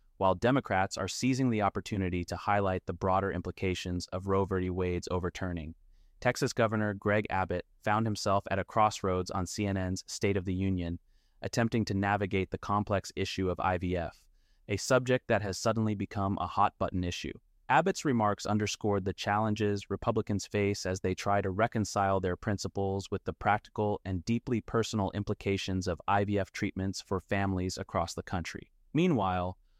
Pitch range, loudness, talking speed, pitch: 95-105 Hz, -31 LUFS, 160 wpm, 100 Hz